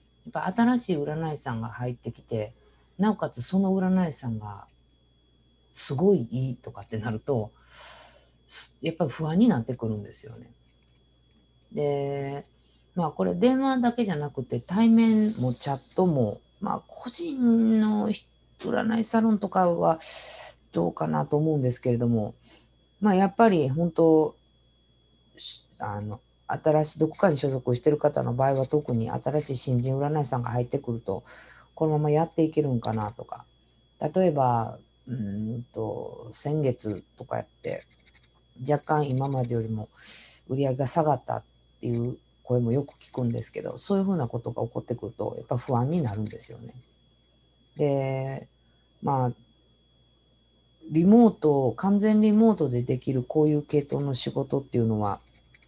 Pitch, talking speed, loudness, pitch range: 135 Hz, 295 characters per minute, -26 LUFS, 115-160 Hz